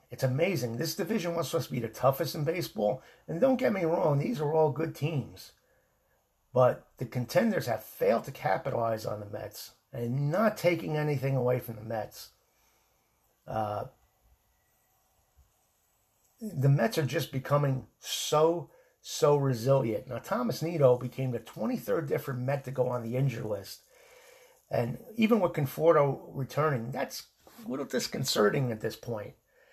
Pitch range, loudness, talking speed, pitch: 125-165 Hz, -30 LUFS, 150 wpm, 140 Hz